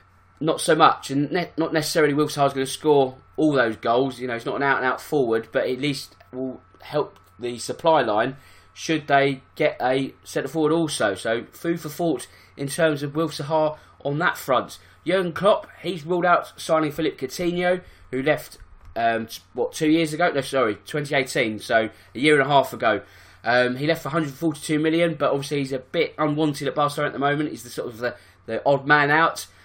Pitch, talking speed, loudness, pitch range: 140 Hz, 200 wpm, -23 LUFS, 125-160 Hz